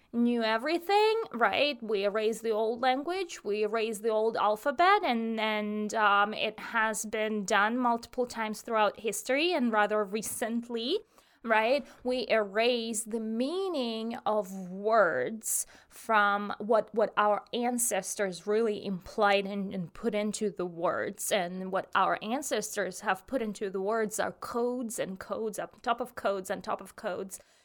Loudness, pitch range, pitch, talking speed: -30 LUFS, 205-240 Hz, 220 Hz, 150 wpm